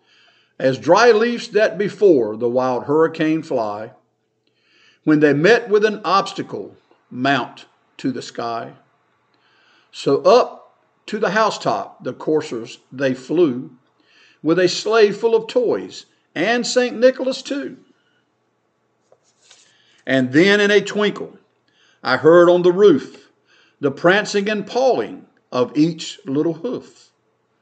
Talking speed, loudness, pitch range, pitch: 120 wpm, -17 LUFS, 150-225 Hz, 185 Hz